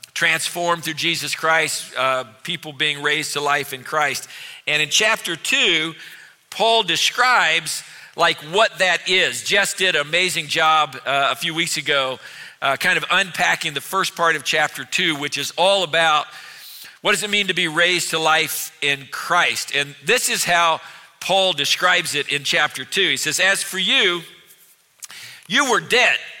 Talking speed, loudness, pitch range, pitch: 170 wpm, -18 LUFS, 145-180 Hz, 160 Hz